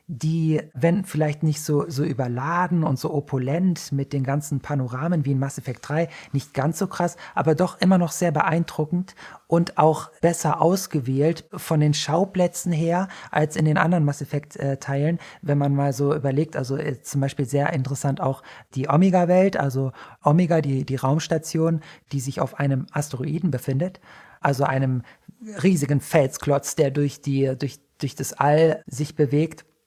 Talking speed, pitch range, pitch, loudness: 165 wpm, 140-165 Hz, 150 Hz, -23 LUFS